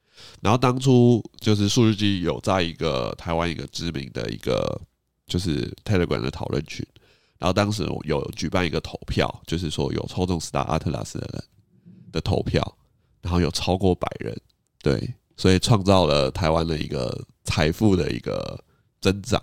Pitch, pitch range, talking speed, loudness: 90 Hz, 80-105 Hz, 270 characters per minute, -24 LUFS